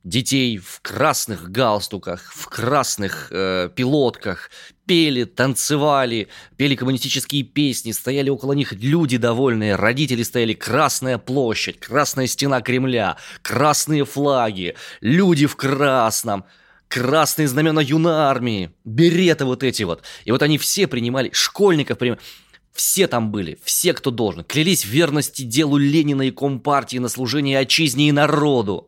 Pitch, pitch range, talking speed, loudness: 135 Hz, 120-150 Hz, 130 wpm, -19 LUFS